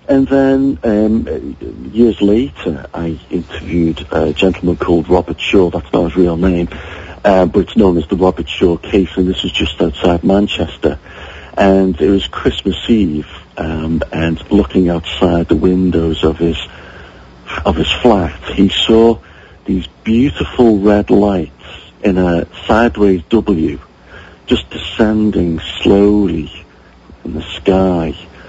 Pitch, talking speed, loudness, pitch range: 90 Hz, 135 wpm, -13 LUFS, 80-100 Hz